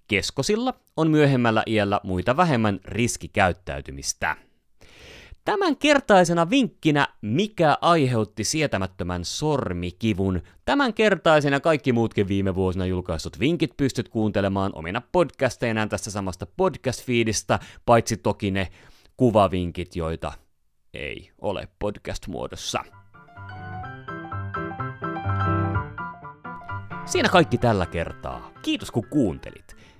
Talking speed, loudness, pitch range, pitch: 90 wpm, -23 LUFS, 95-150 Hz, 110 Hz